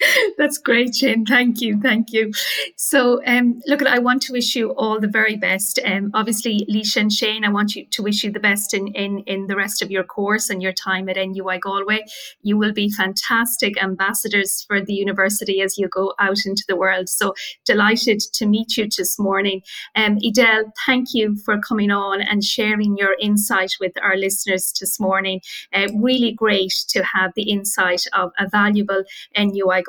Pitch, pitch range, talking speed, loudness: 205 Hz, 195-220 Hz, 195 wpm, -18 LUFS